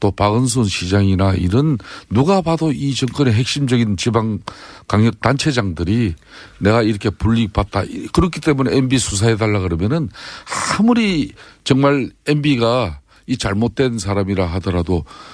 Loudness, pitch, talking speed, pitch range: -17 LUFS, 115 Hz, 300 characters per minute, 100-135 Hz